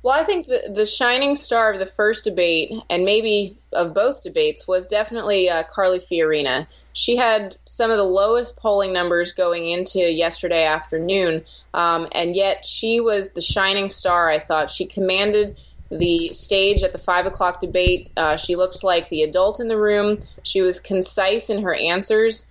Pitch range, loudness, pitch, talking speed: 175-215 Hz, -19 LUFS, 190 Hz, 180 wpm